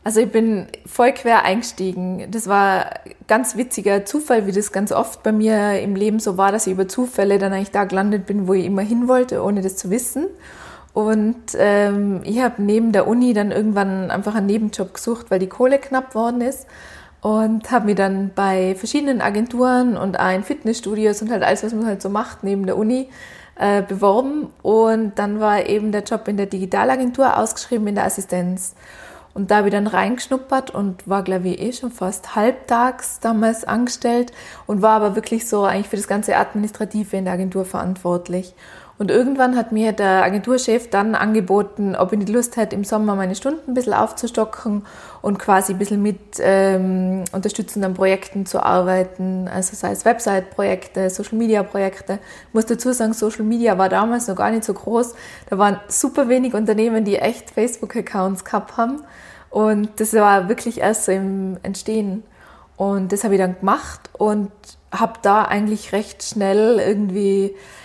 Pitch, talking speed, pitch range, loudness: 210 Hz, 180 wpm, 195-225 Hz, -19 LUFS